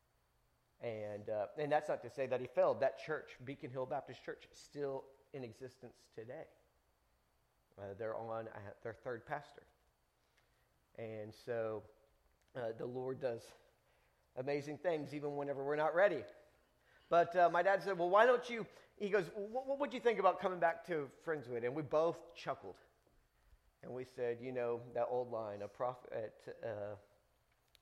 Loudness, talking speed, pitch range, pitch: -39 LUFS, 165 wpm, 115-165 Hz, 135 Hz